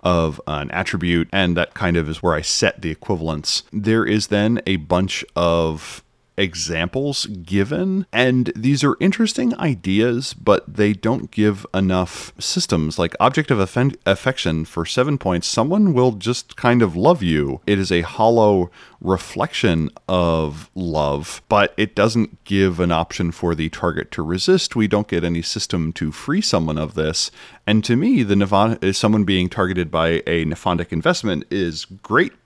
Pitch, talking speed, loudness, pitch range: 95 Hz, 165 wpm, -19 LUFS, 85-115 Hz